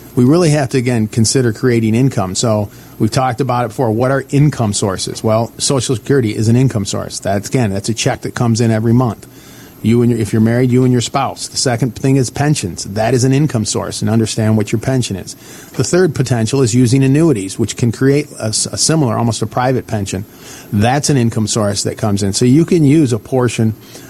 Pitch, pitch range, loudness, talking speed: 120 Hz, 110-135 Hz, -14 LUFS, 225 wpm